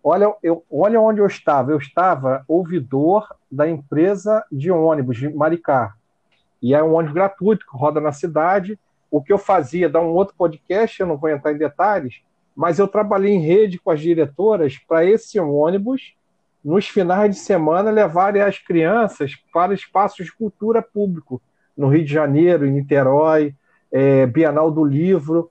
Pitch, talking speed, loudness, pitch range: 165 Hz, 165 wpm, -18 LUFS, 150-200 Hz